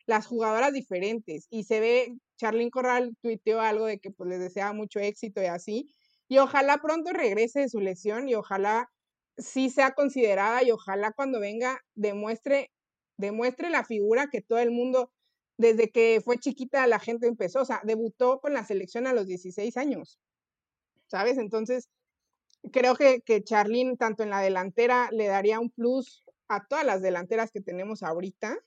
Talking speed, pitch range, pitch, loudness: 170 wpm, 210-255 Hz, 230 Hz, -27 LUFS